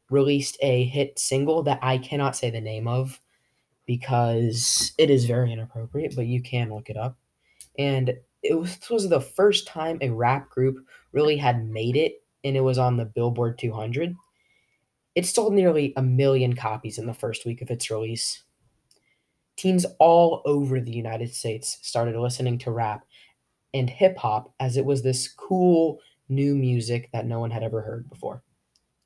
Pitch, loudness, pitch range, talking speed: 130 Hz, -24 LUFS, 120-145 Hz, 170 wpm